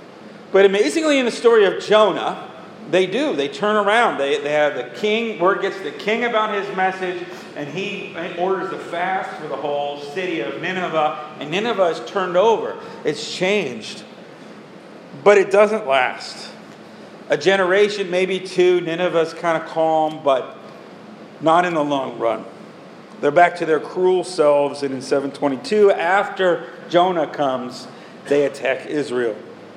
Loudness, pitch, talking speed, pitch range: -19 LUFS, 180 Hz, 155 wpm, 155-200 Hz